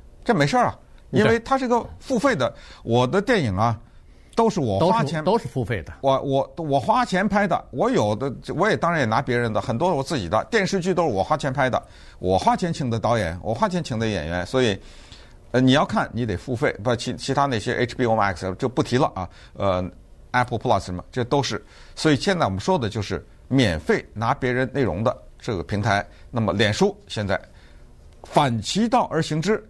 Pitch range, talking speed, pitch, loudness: 105-155 Hz, 310 characters per minute, 125 Hz, -22 LUFS